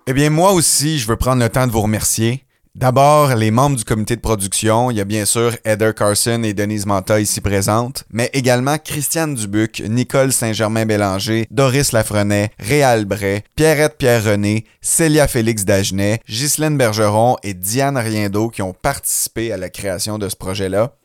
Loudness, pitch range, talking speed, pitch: -16 LUFS, 105-130 Hz, 170 wpm, 110 Hz